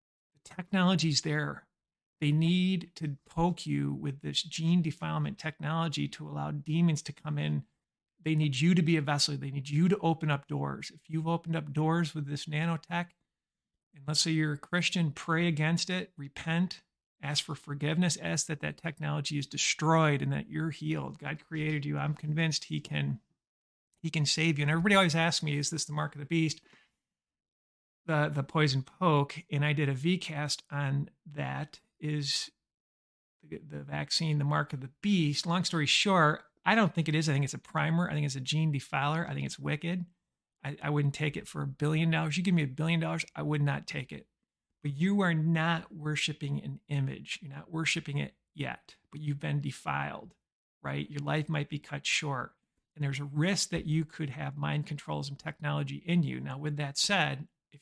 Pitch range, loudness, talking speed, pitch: 145-165 Hz, -31 LUFS, 195 wpm, 150 Hz